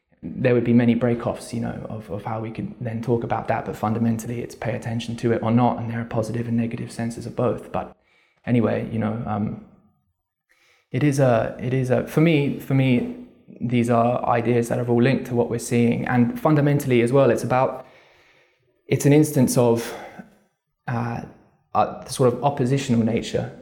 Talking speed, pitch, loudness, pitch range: 195 wpm, 120 Hz, -22 LUFS, 115-130 Hz